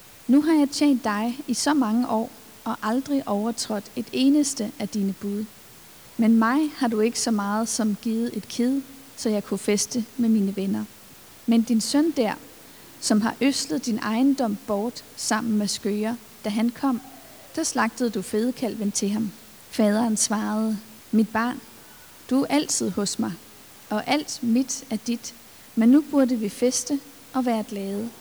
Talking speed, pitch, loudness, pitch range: 170 wpm, 230 Hz, -24 LUFS, 215-260 Hz